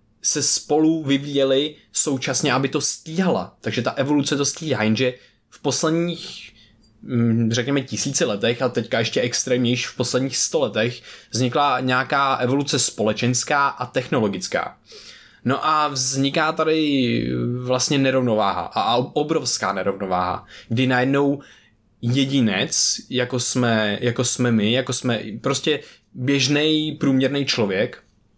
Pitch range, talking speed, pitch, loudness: 120-140 Hz, 115 wpm, 130 Hz, -20 LUFS